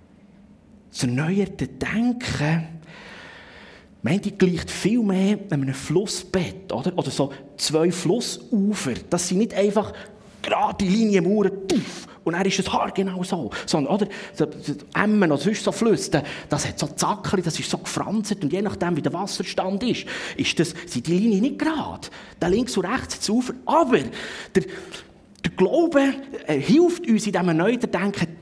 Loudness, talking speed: -23 LUFS, 155 wpm